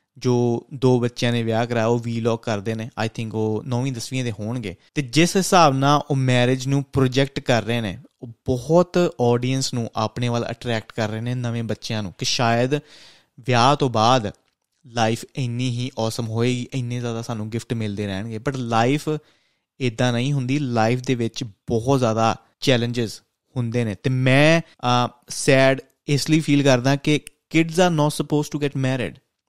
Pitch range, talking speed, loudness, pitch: 115-140 Hz, 170 wpm, -21 LUFS, 125 Hz